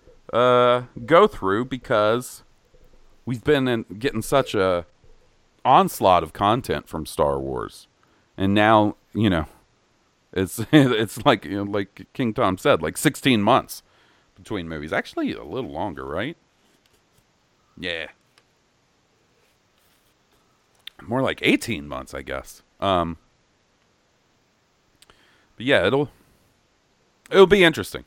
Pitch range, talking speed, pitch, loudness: 95-130 Hz, 115 wpm, 110 Hz, -21 LUFS